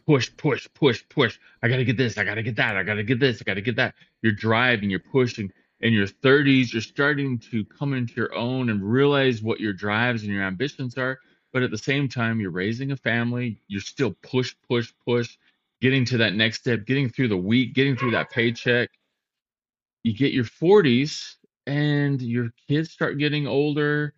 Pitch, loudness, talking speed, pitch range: 125 Hz, -23 LUFS, 210 wpm, 115-135 Hz